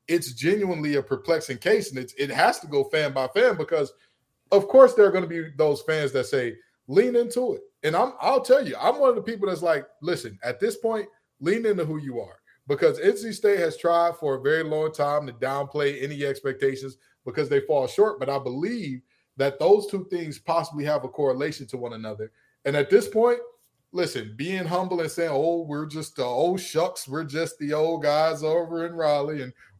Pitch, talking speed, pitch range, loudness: 165 Hz, 215 wpm, 140-215 Hz, -24 LUFS